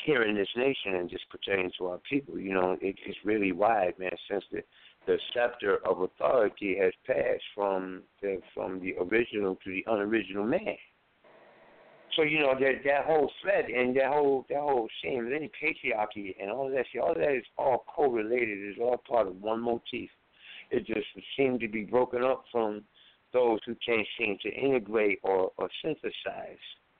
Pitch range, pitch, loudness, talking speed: 95-135 Hz, 110 Hz, -30 LUFS, 185 wpm